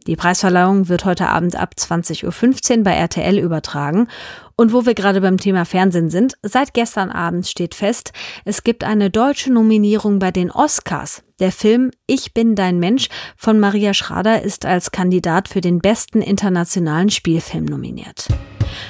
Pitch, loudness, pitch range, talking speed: 195 Hz, -16 LUFS, 175-220 Hz, 160 wpm